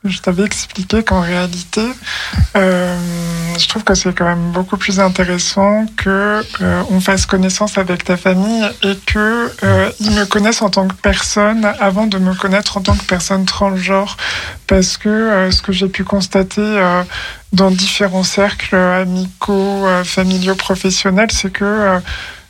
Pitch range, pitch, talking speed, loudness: 185-205 Hz, 195 Hz, 165 wpm, -14 LUFS